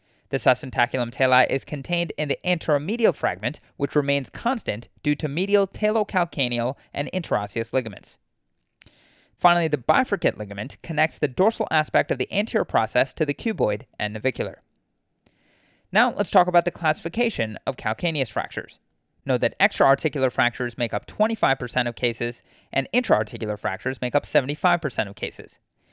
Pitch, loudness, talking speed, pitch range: 140 Hz, -23 LUFS, 145 wpm, 120-175 Hz